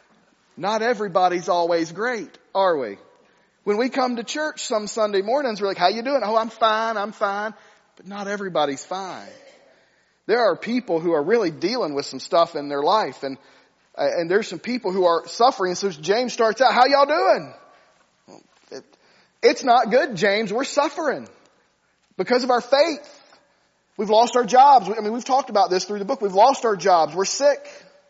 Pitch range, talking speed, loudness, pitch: 185-250 Hz, 190 wpm, -21 LUFS, 210 Hz